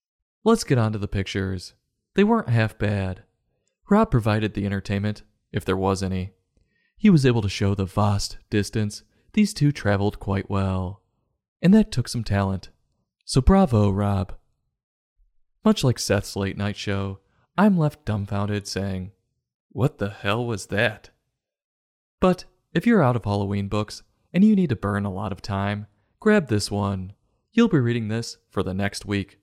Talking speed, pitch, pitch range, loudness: 165 wpm, 105 Hz, 100-120 Hz, -23 LUFS